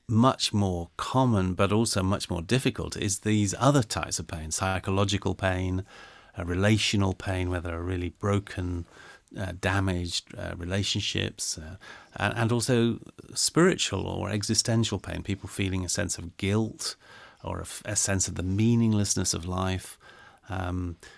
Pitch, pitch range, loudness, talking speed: 95 Hz, 90-105 Hz, -27 LUFS, 150 wpm